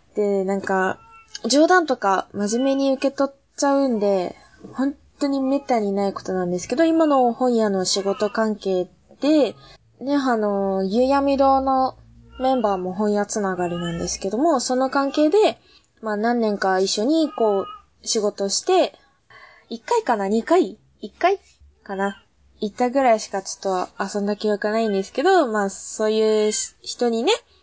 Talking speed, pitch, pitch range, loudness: 295 characters per minute, 220 Hz, 195-275 Hz, -21 LUFS